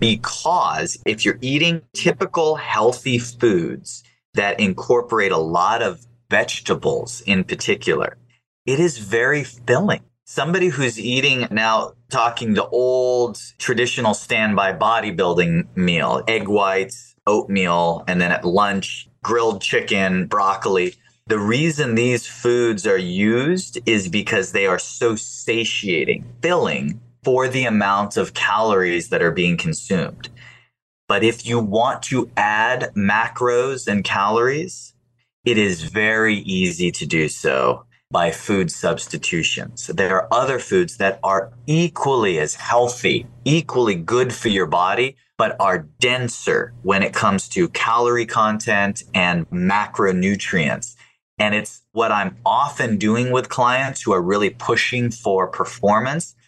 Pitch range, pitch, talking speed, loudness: 105-130 Hz, 120 Hz, 130 wpm, -19 LUFS